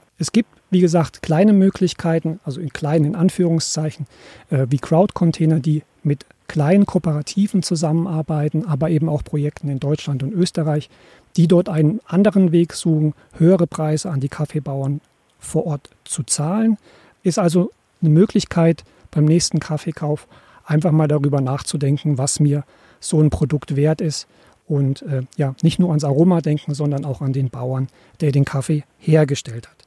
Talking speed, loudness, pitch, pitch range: 155 wpm, -19 LUFS, 155 Hz, 145-170 Hz